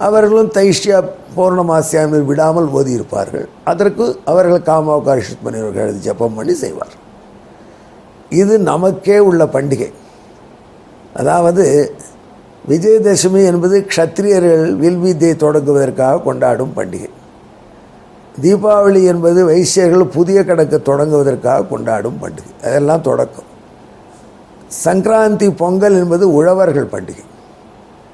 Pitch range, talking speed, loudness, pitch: 150-195 Hz, 85 wpm, -12 LUFS, 175 Hz